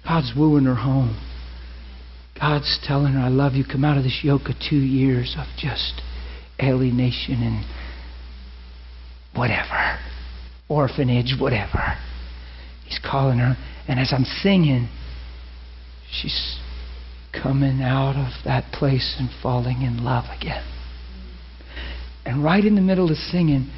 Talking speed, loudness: 125 wpm, -21 LUFS